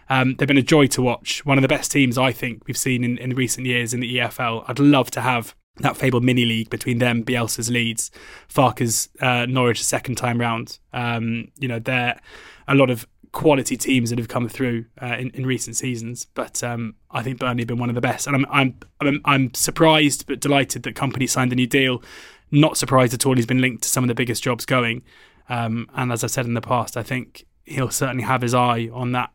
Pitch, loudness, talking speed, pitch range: 125 Hz, -20 LUFS, 235 wpm, 120-130 Hz